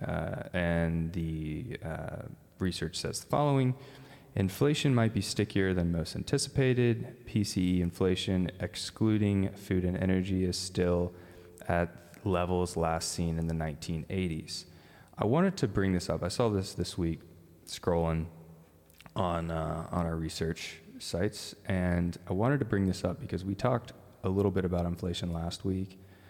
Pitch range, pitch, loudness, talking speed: 85-100 Hz, 90 Hz, -32 LUFS, 150 wpm